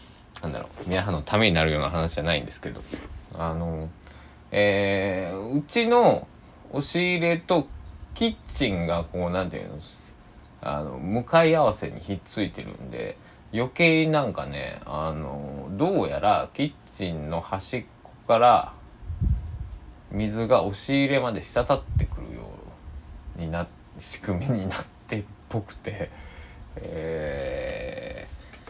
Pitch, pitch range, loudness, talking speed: 95 Hz, 80-125 Hz, -26 LUFS, 240 characters per minute